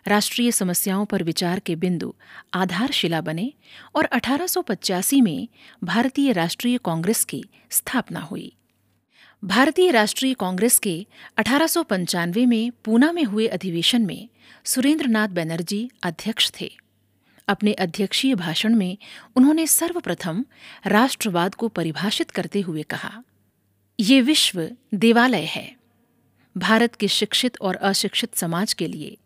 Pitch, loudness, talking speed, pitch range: 215 Hz, -21 LUFS, 115 wpm, 185-250 Hz